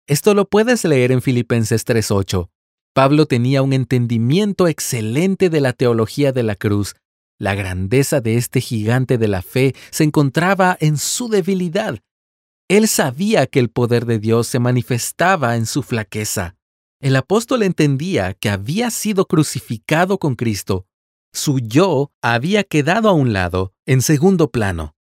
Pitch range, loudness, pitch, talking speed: 110-160 Hz, -17 LUFS, 130 Hz, 150 wpm